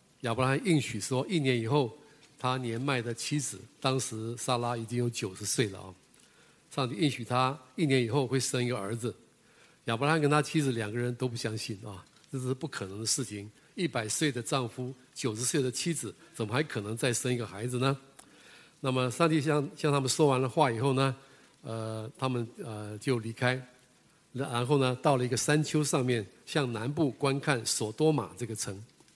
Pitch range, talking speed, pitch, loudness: 115-145 Hz, 280 characters per minute, 130 Hz, -31 LUFS